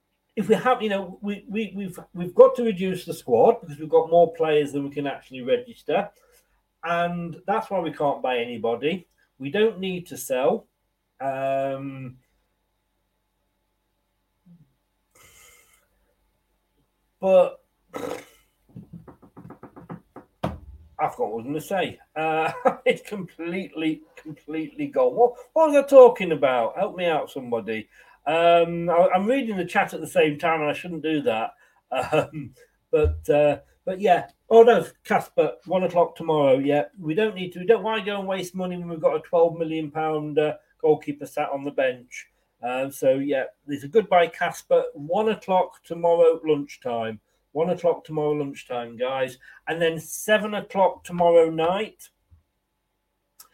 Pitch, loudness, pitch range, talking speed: 165 Hz, -23 LUFS, 140-195 Hz, 150 wpm